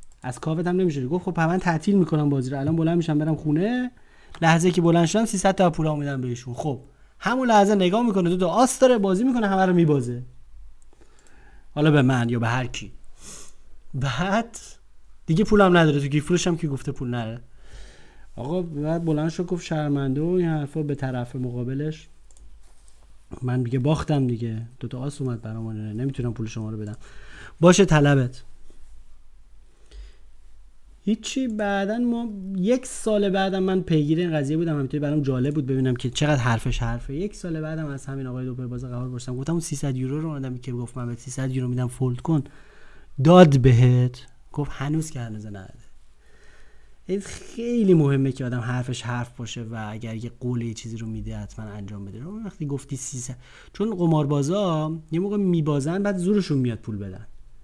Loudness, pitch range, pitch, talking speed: -23 LUFS, 120-175 Hz, 140 Hz, 175 wpm